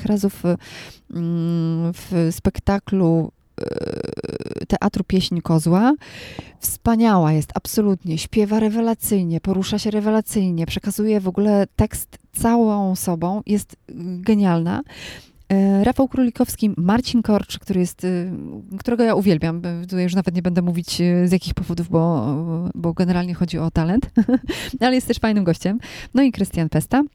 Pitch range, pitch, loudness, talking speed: 175-215 Hz, 195 Hz, -20 LUFS, 125 wpm